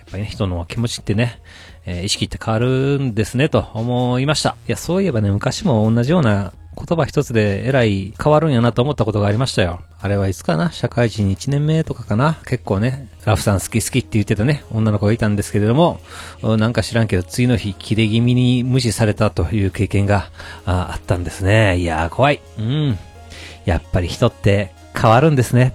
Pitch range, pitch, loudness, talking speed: 100-125 Hz, 110 Hz, -18 LUFS, 400 characters per minute